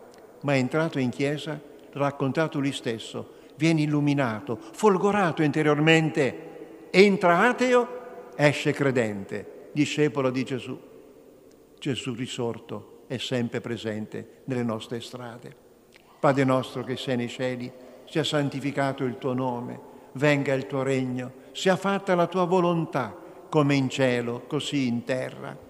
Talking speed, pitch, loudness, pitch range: 125 wpm, 140 Hz, -25 LUFS, 125-155 Hz